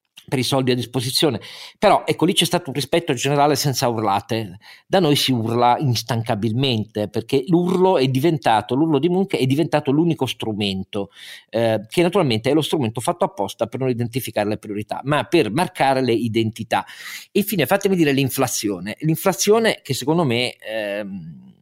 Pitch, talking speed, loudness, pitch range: 135 Hz, 160 wpm, -20 LUFS, 115-165 Hz